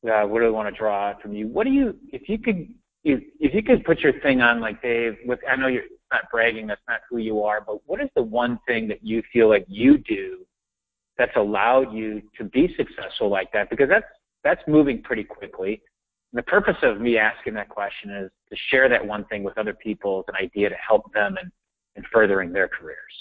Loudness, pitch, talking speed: -22 LUFS, 115 Hz, 235 wpm